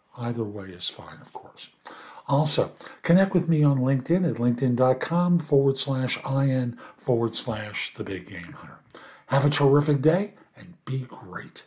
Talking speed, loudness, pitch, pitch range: 155 wpm, -25 LUFS, 130 Hz, 115-150 Hz